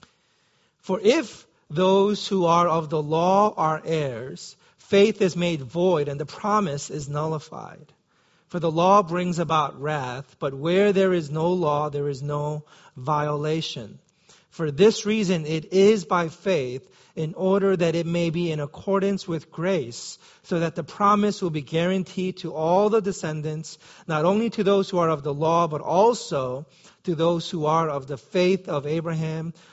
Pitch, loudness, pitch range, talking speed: 170 Hz, -23 LUFS, 155-190 Hz, 170 wpm